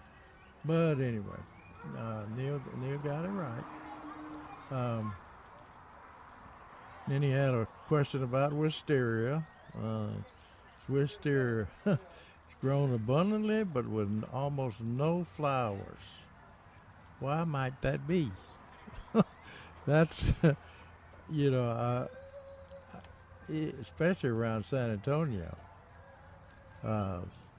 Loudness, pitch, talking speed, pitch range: -34 LUFS, 120 Hz, 85 wpm, 100-145 Hz